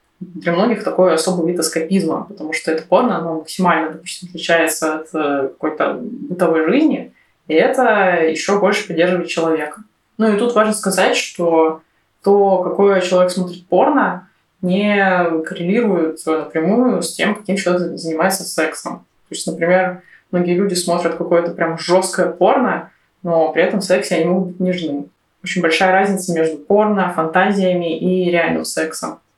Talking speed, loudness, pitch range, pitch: 145 wpm, -16 LUFS, 160-190 Hz, 175 Hz